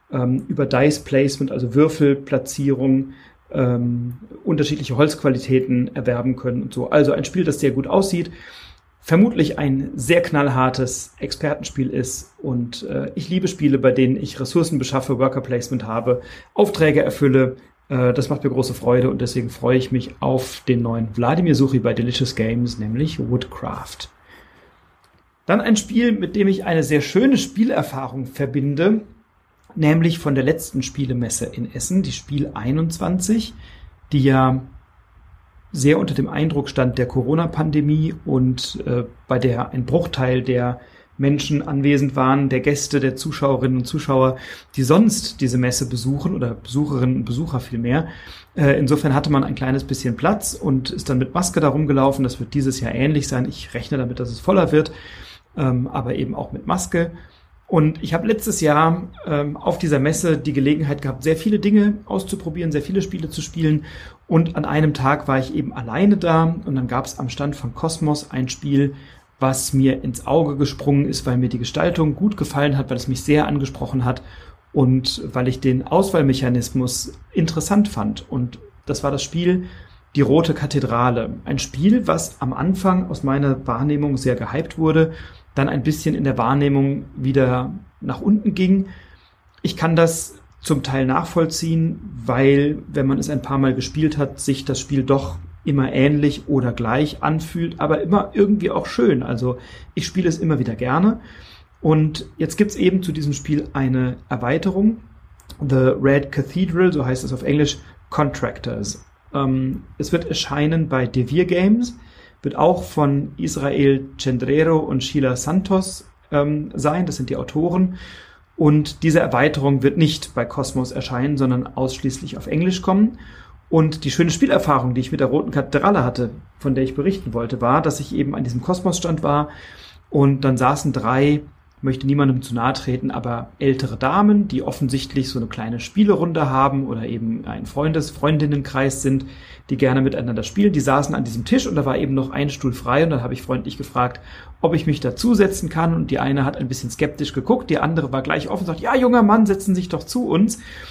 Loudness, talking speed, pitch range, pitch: -20 LUFS, 175 wpm, 130-160 Hz, 140 Hz